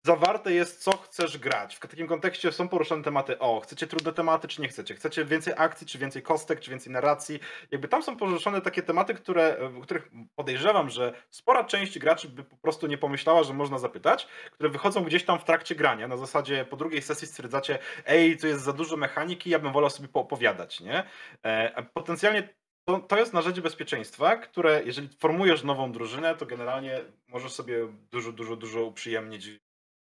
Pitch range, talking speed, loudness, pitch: 130-170 Hz, 185 wpm, -28 LUFS, 155 Hz